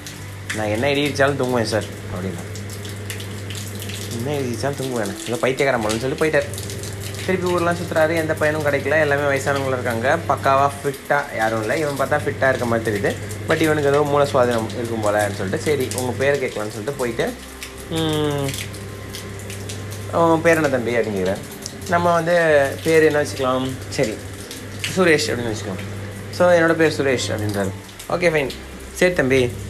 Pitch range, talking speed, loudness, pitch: 100-145 Hz, 140 wpm, -20 LUFS, 120 Hz